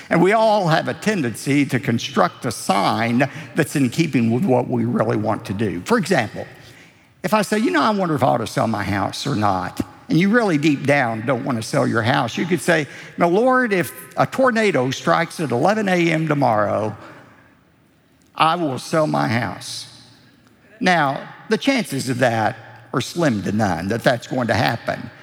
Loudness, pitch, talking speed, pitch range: -19 LUFS, 160 Hz, 195 wpm, 130-200 Hz